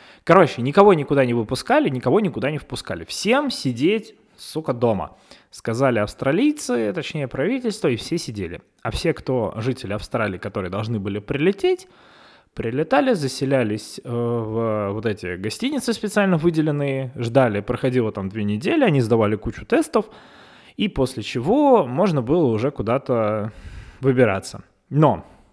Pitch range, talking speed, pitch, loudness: 110-165 Hz, 130 wpm, 130 Hz, -21 LUFS